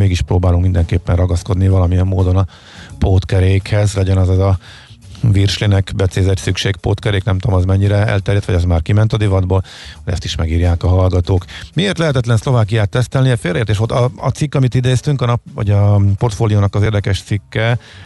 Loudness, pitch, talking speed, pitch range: -15 LUFS, 100 Hz, 175 wpm, 95-115 Hz